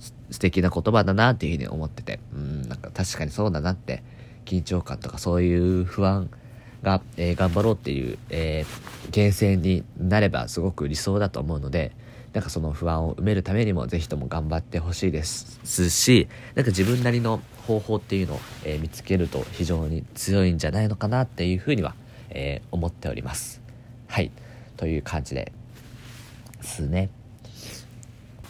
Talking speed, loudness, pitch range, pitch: 345 characters per minute, -25 LUFS, 85-115 Hz, 95 Hz